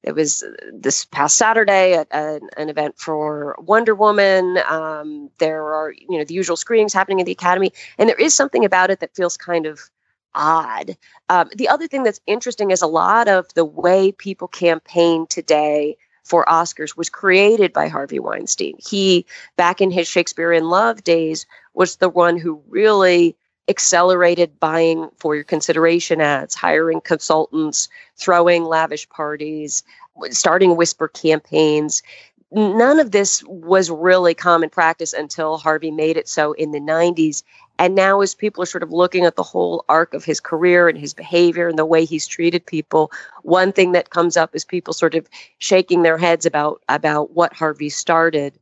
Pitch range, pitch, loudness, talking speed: 155-185 Hz, 170 Hz, -17 LUFS, 170 wpm